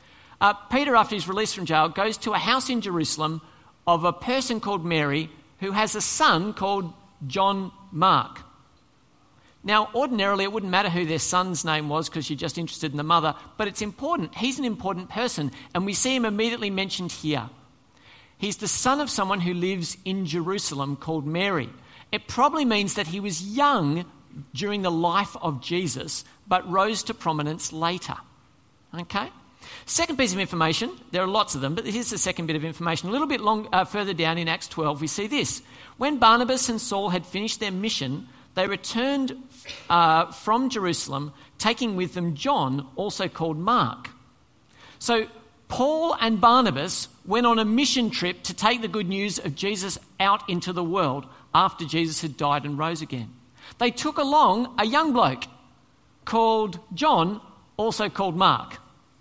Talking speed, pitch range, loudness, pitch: 175 wpm, 160-220 Hz, -24 LUFS, 190 Hz